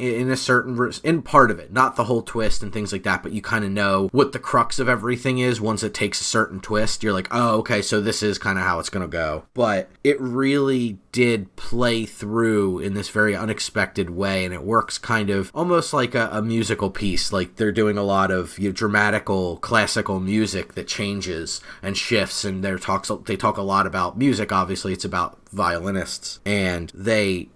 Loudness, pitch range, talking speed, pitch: -22 LUFS, 95-115 Hz, 210 wpm, 105 Hz